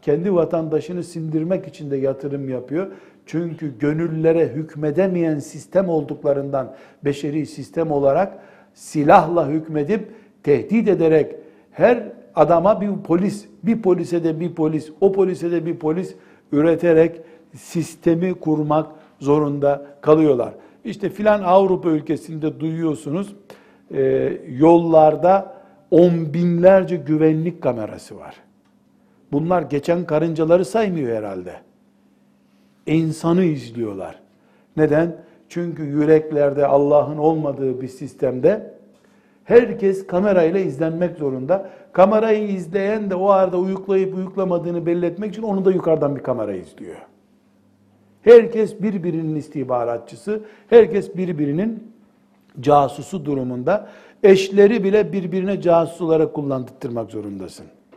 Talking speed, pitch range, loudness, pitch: 100 wpm, 145-190 Hz, -19 LUFS, 165 Hz